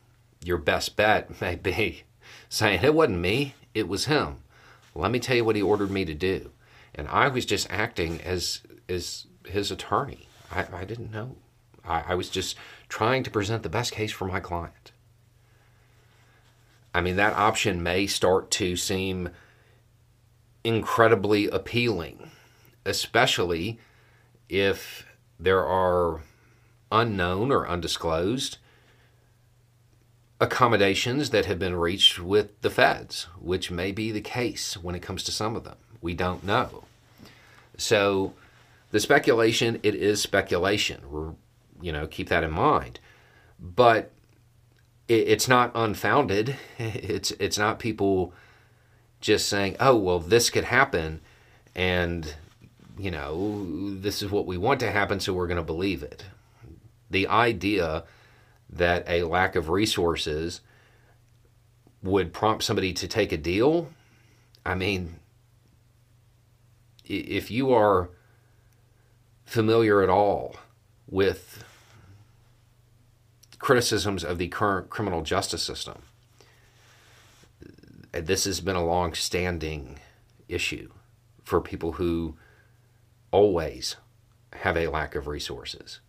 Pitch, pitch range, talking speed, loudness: 110 Hz, 95-115 Hz, 125 wpm, -25 LUFS